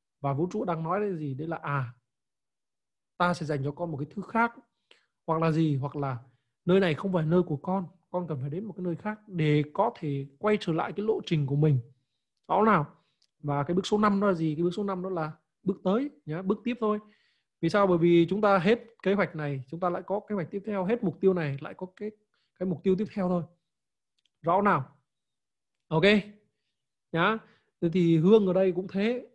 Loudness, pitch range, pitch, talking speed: -28 LUFS, 150-200 Hz, 180 Hz, 235 wpm